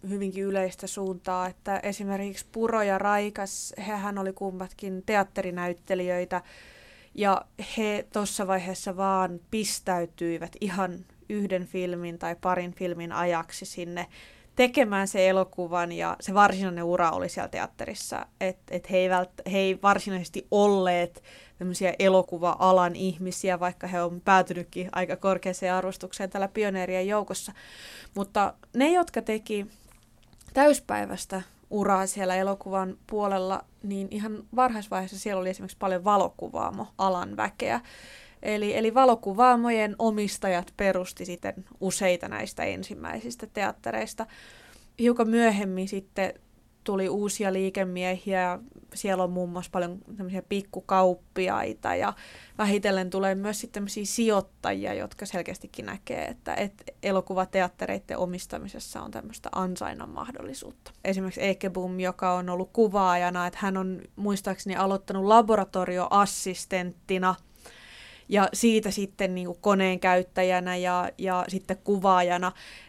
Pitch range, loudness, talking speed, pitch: 185-205 Hz, -27 LUFS, 115 wpm, 190 Hz